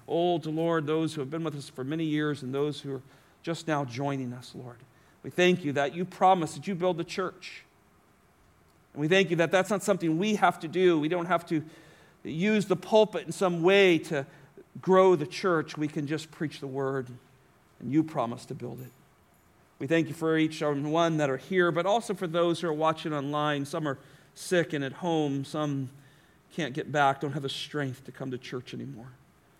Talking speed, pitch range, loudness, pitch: 215 wpm, 140-170 Hz, -28 LUFS, 155 Hz